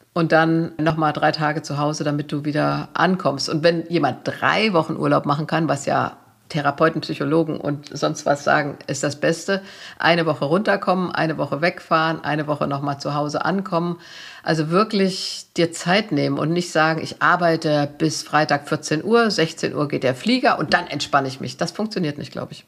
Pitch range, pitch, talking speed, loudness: 150-175 Hz, 160 Hz, 190 wpm, -21 LUFS